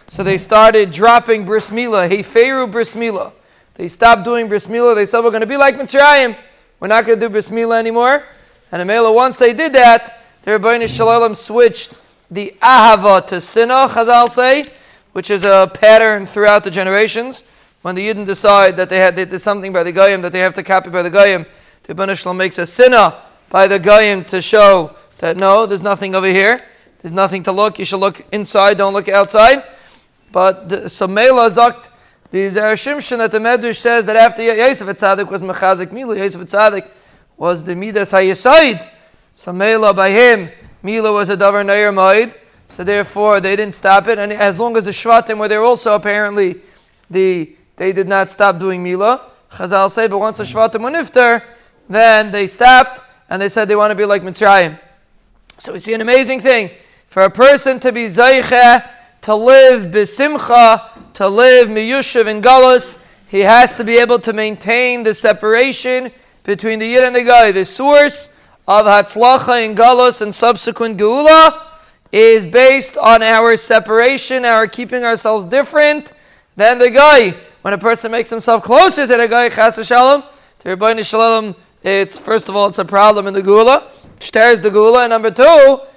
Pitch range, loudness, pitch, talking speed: 200-240 Hz, -10 LUFS, 220 Hz, 180 wpm